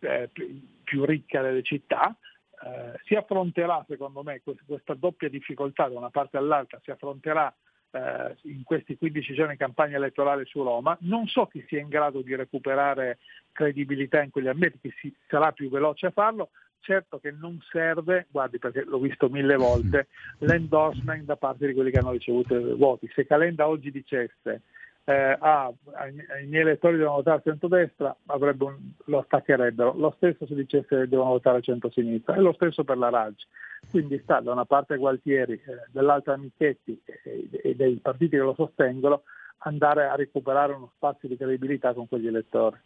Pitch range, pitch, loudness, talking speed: 135-155 Hz, 140 Hz, -26 LUFS, 175 wpm